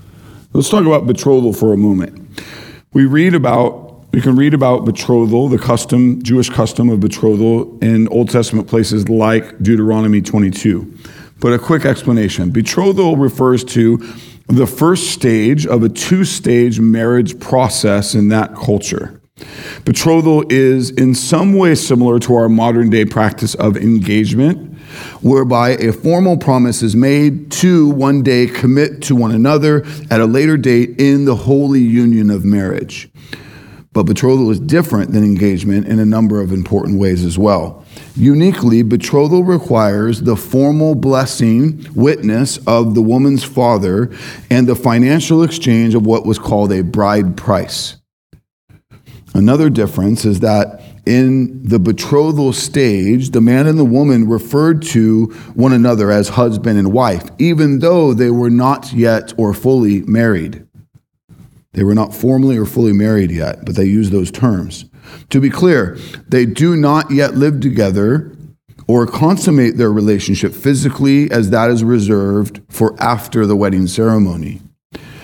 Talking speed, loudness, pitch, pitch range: 145 wpm, -12 LUFS, 120 Hz, 110-135 Hz